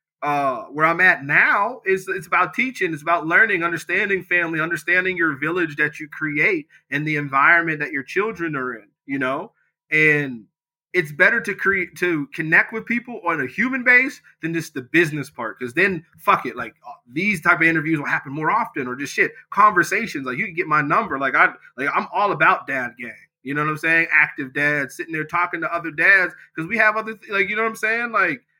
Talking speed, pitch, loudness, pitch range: 215 wpm, 165 Hz, -19 LUFS, 155-195 Hz